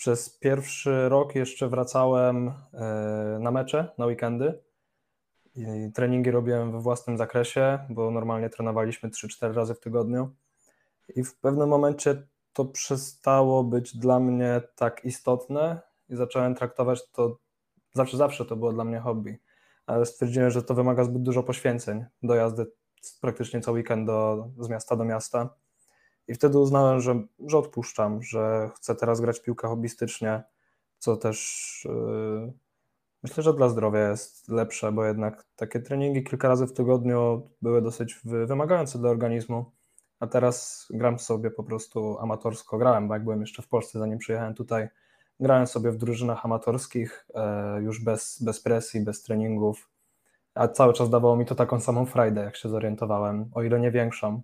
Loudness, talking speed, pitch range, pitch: -26 LUFS, 155 wpm, 115-125 Hz, 120 Hz